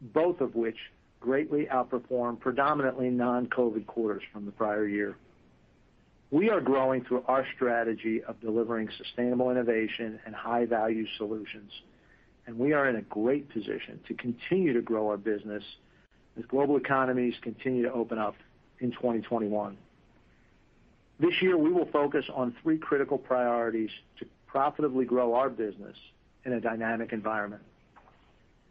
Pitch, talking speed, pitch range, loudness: 120 Hz, 140 wpm, 110-130 Hz, -30 LUFS